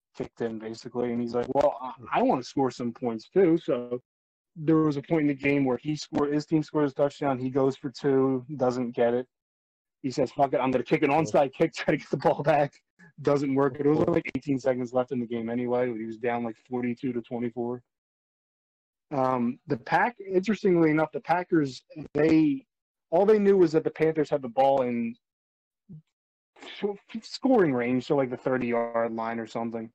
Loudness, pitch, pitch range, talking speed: -27 LUFS, 135 Hz, 120-155 Hz, 205 wpm